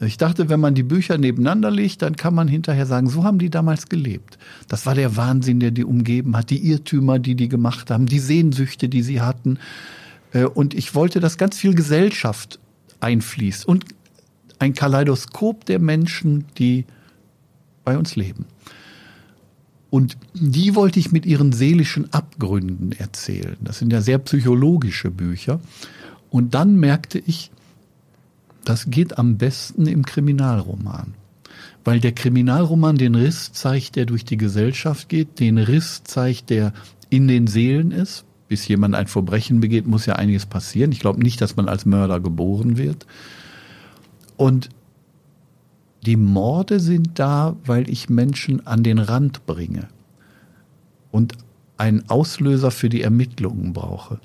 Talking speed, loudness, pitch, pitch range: 150 wpm, -19 LUFS, 130 Hz, 115-155 Hz